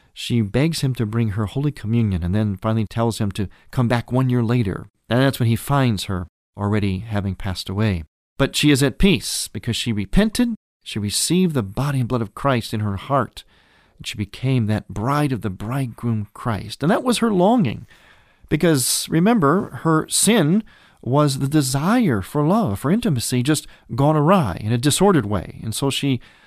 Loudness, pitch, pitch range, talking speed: -20 LUFS, 125 Hz, 105-150 Hz, 190 wpm